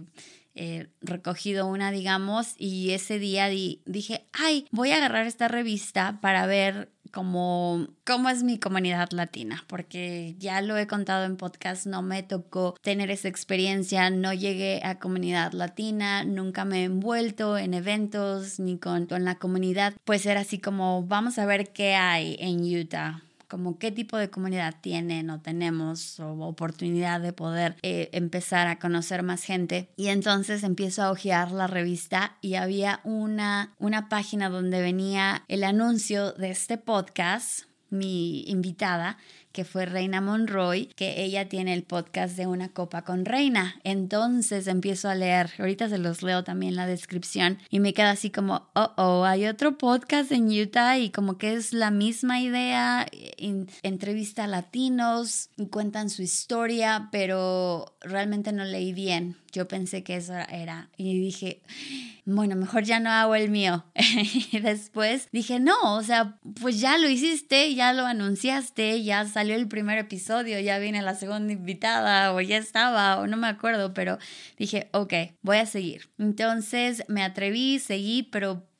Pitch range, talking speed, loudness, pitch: 185-215 Hz, 165 wpm, -27 LUFS, 195 Hz